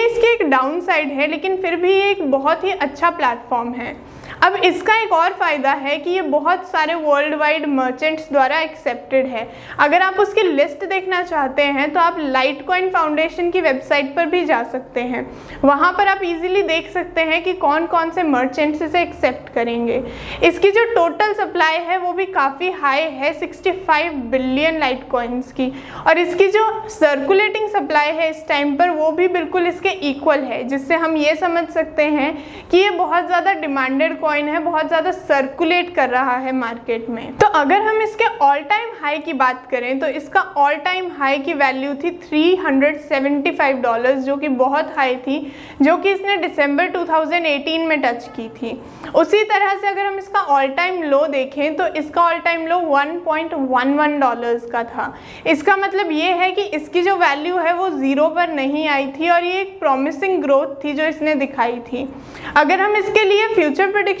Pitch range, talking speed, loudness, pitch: 280-360 Hz, 160 wpm, -17 LUFS, 315 Hz